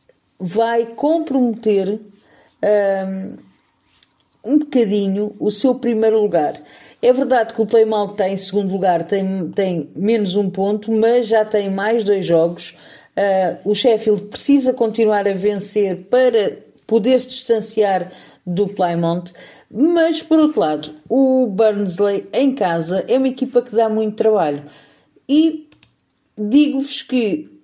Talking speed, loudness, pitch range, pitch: 130 wpm, -17 LUFS, 195-250 Hz, 215 Hz